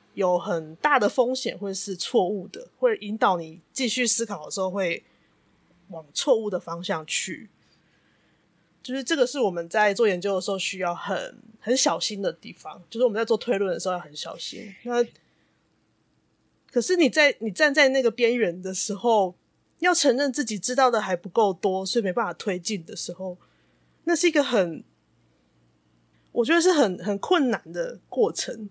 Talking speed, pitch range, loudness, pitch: 255 characters per minute, 180-245 Hz, -24 LUFS, 210 Hz